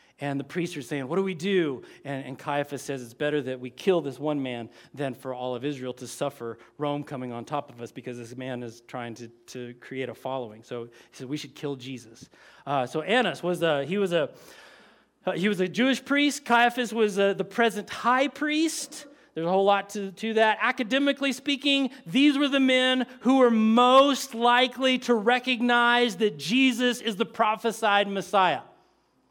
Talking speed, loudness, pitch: 195 wpm, -25 LUFS, 190 Hz